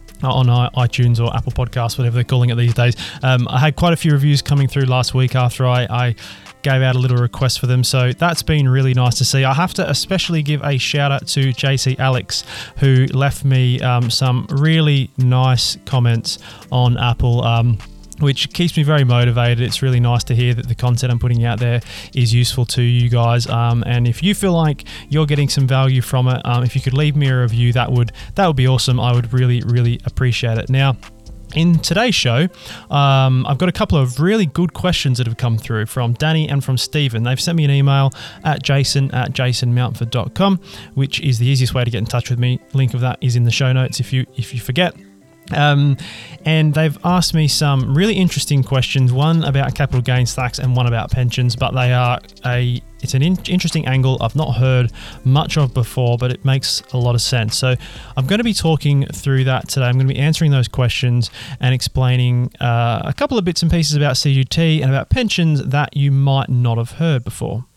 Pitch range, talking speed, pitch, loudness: 120-145 Hz, 220 wpm, 130 Hz, -16 LUFS